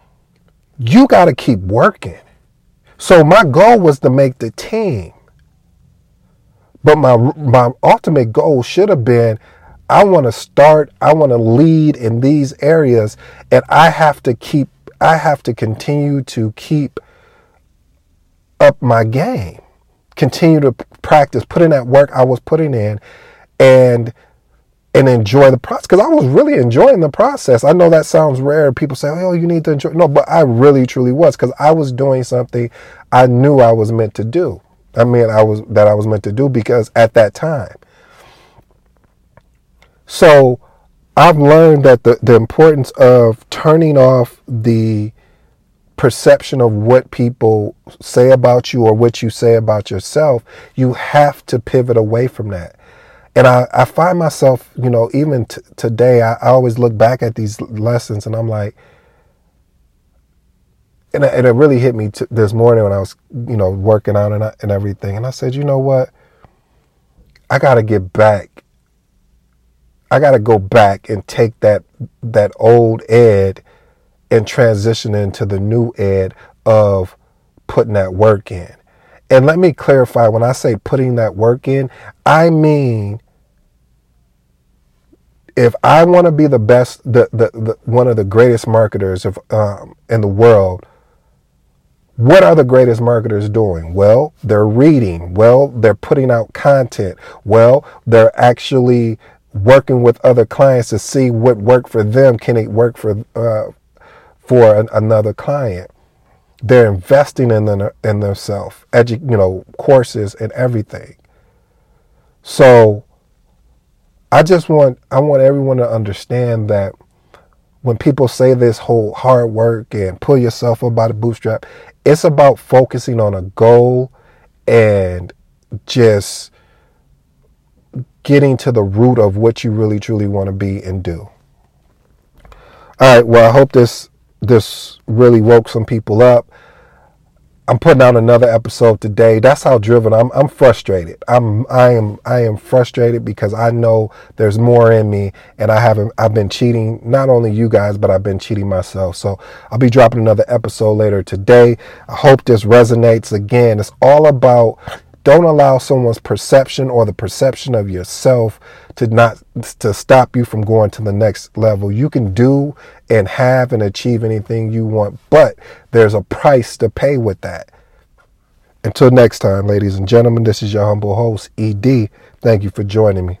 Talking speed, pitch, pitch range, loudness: 160 wpm, 115 Hz, 105-130 Hz, -11 LUFS